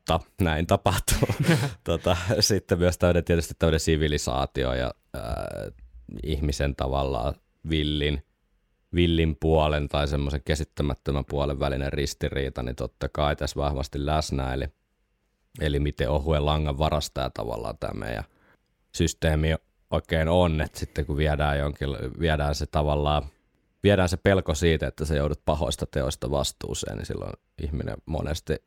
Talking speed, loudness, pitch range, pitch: 130 wpm, -26 LUFS, 70-85 Hz, 75 Hz